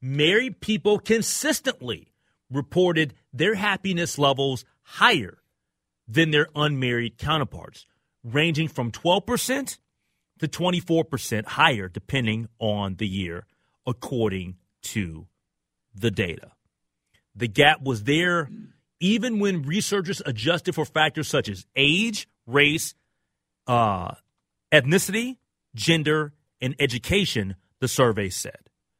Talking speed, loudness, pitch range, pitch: 100 wpm, -23 LUFS, 115-180 Hz, 145 Hz